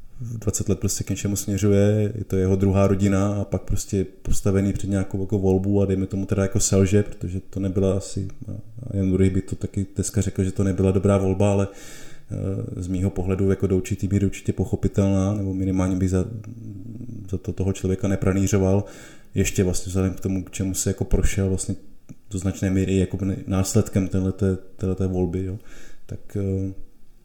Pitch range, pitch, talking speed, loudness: 95-100 Hz, 95 Hz, 180 wpm, -23 LUFS